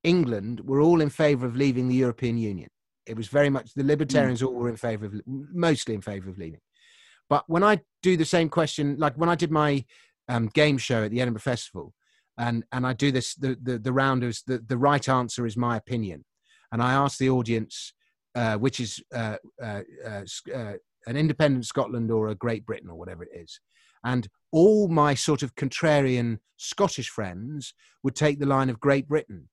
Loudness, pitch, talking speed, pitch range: -25 LUFS, 130 Hz, 200 wpm, 115-145 Hz